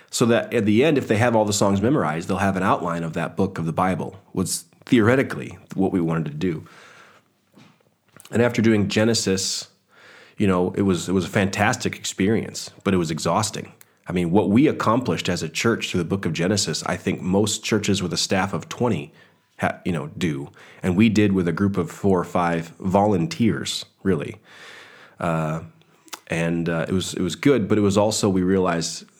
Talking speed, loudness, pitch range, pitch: 200 wpm, -22 LUFS, 85-105 Hz, 95 Hz